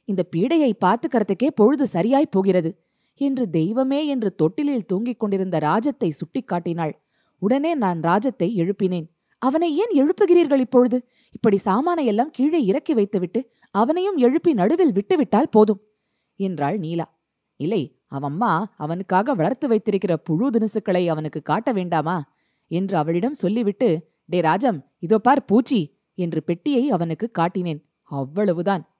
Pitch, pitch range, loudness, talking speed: 205 Hz, 175-255 Hz, -21 LUFS, 120 wpm